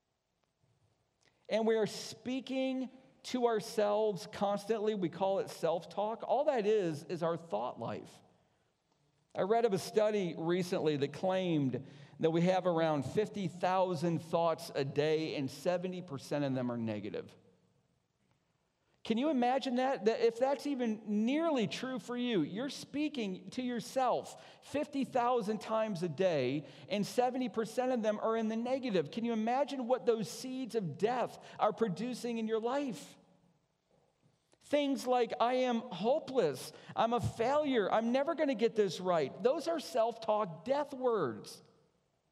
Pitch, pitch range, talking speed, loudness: 220 Hz, 180-250 Hz, 145 wpm, -34 LUFS